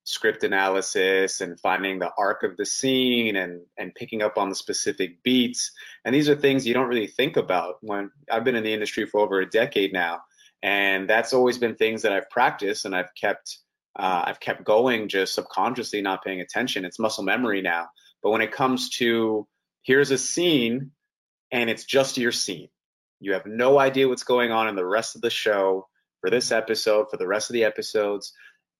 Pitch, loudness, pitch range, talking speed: 110 Hz, -23 LUFS, 95-130 Hz, 200 wpm